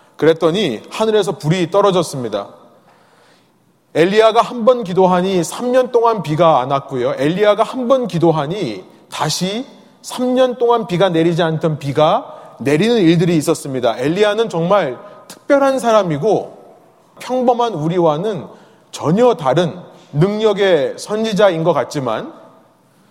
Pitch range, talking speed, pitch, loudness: 165-230 Hz, 275 characters per minute, 195 Hz, -15 LUFS